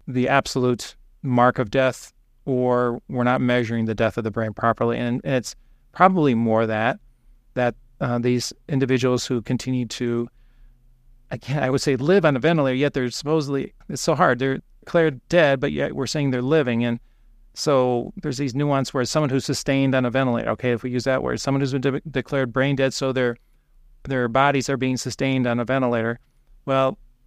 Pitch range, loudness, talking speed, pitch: 120-135 Hz, -22 LUFS, 190 wpm, 130 Hz